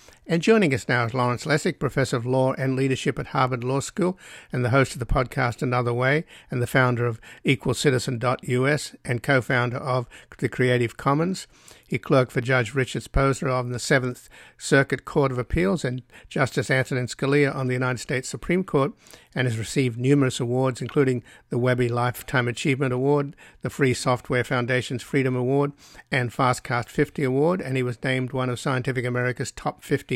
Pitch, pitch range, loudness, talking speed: 130 Hz, 125-140 Hz, -24 LUFS, 175 wpm